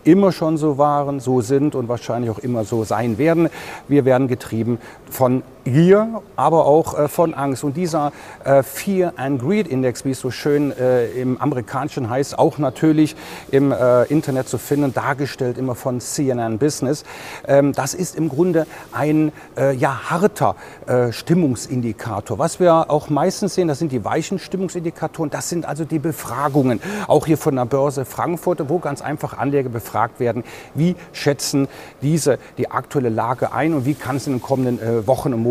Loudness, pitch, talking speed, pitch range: -19 LUFS, 140 Hz, 175 wpm, 125-160 Hz